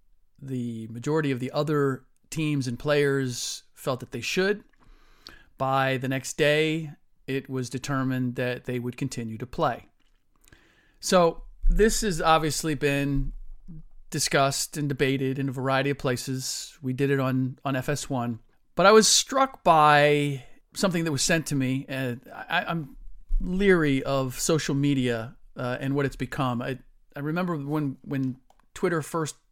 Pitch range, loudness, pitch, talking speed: 130-155 Hz, -26 LUFS, 140 Hz, 150 wpm